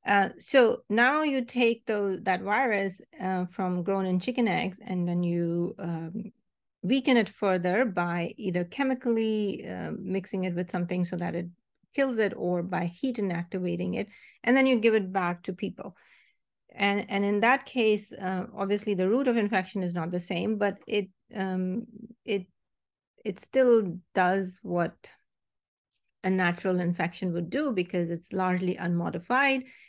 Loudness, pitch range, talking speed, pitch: -28 LUFS, 180-230 Hz, 160 wpm, 195 Hz